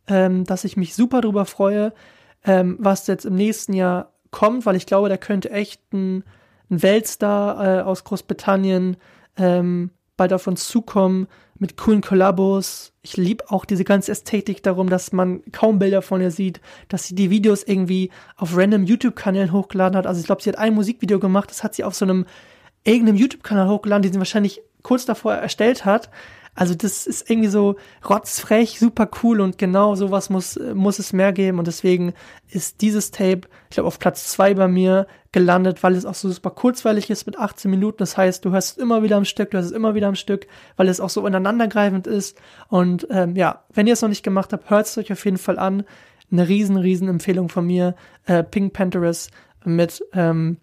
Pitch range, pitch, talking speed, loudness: 185-210 Hz, 195 Hz, 205 wpm, -19 LUFS